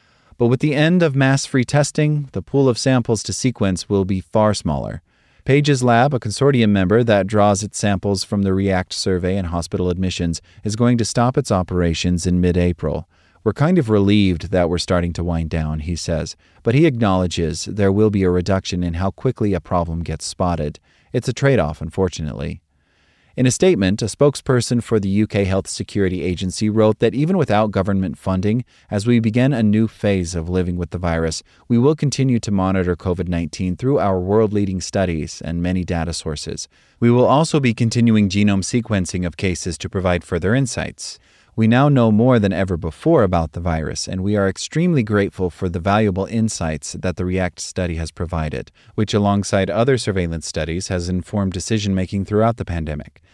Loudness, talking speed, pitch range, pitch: -19 LUFS, 190 wpm, 90-115 Hz, 95 Hz